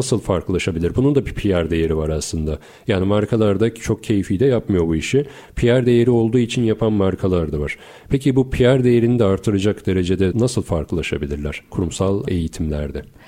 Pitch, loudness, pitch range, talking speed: 100 Hz, -19 LUFS, 85-120 Hz, 160 wpm